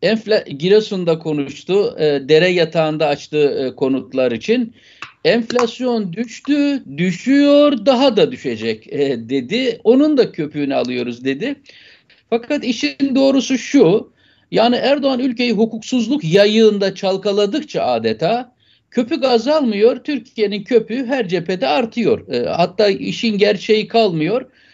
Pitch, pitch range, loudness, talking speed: 220 Hz, 165-250 Hz, -16 LUFS, 110 wpm